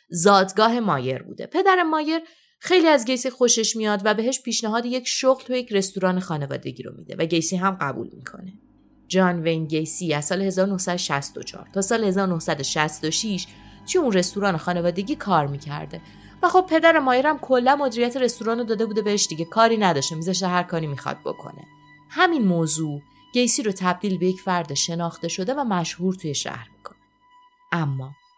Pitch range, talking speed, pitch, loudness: 165-245 Hz, 165 wpm, 195 Hz, -21 LUFS